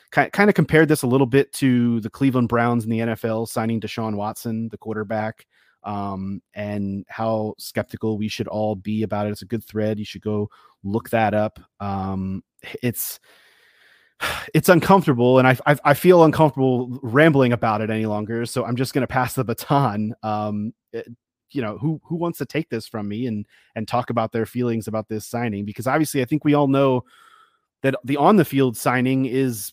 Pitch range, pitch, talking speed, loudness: 110-135 Hz, 120 Hz, 195 wpm, -21 LUFS